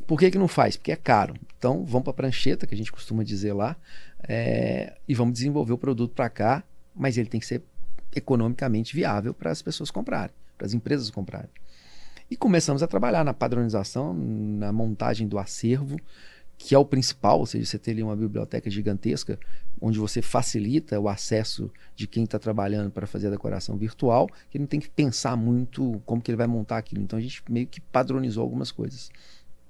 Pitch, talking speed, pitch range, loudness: 115 Hz, 200 wpm, 105-135 Hz, -26 LUFS